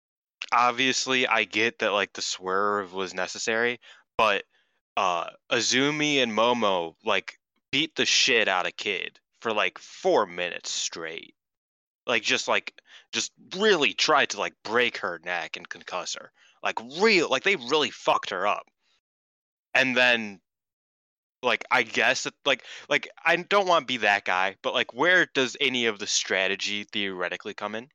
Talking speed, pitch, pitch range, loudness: 160 wpm, 110 Hz, 100-130 Hz, -25 LUFS